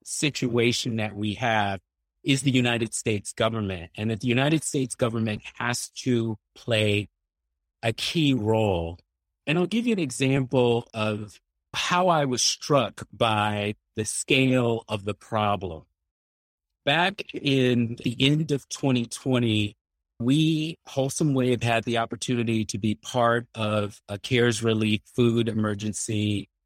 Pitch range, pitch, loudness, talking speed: 105-125 Hz, 115 Hz, -25 LUFS, 135 wpm